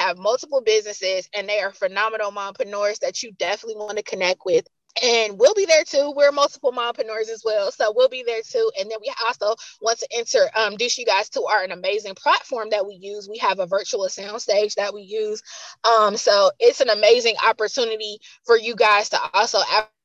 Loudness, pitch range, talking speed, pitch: -20 LUFS, 205-285 Hz, 205 wpm, 220 Hz